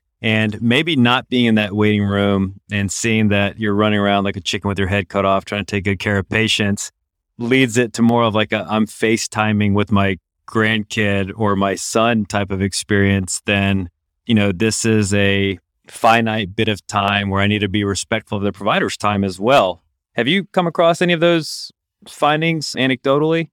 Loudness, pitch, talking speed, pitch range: -17 LUFS, 105 Hz, 200 wpm, 100-115 Hz